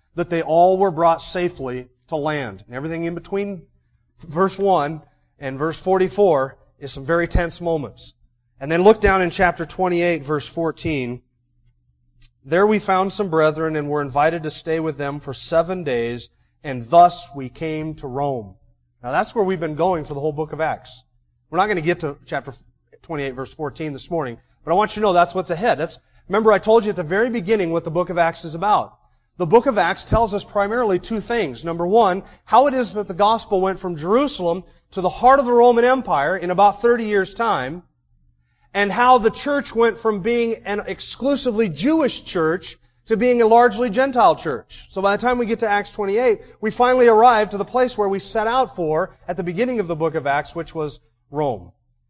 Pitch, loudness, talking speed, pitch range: 175 Hz, -19 LUFS, 210 wpm, 150-210 Hz